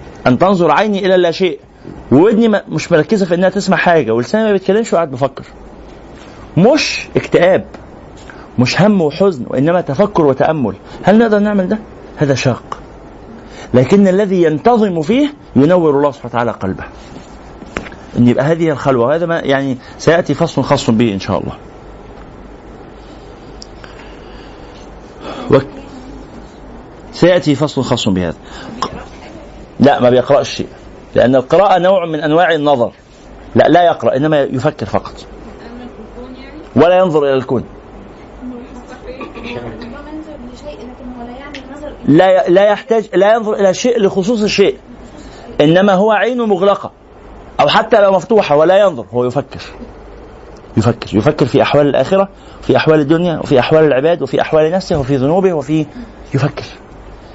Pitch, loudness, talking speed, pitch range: 165 Hz, -12 LUFS, 125 wpm, 135-200 Hz